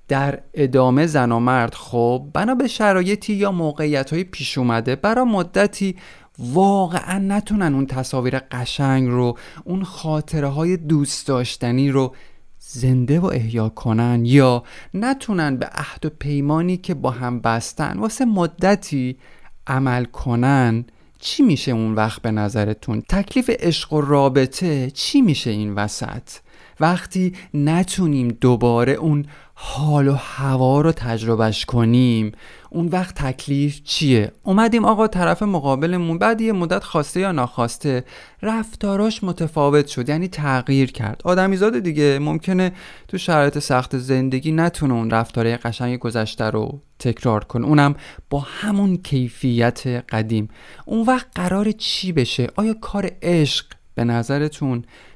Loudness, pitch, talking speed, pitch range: -19 LUFS, 140 Hz, 130 wpm, 125-180 Hz